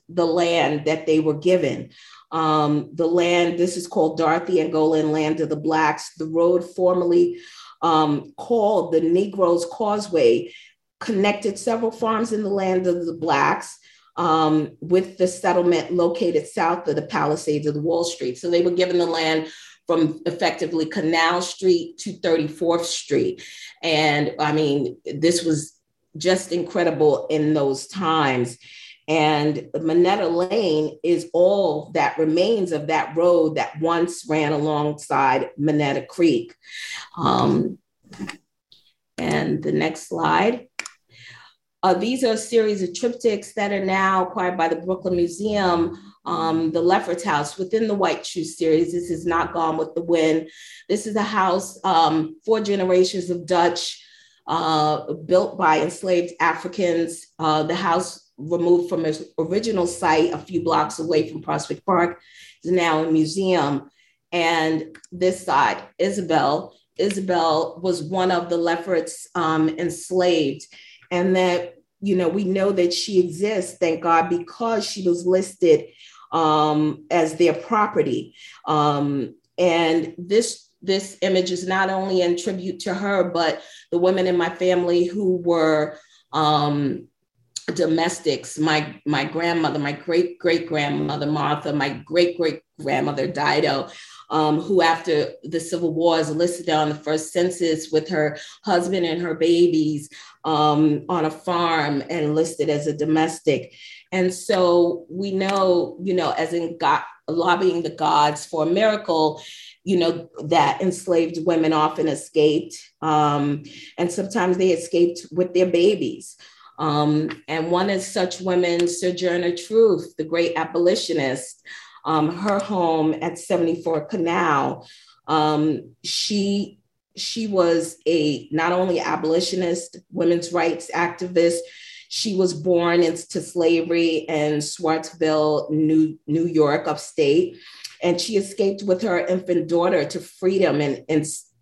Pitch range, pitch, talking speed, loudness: 155-185 Hz, 170 Hz, 140 wpm, -21 LUFS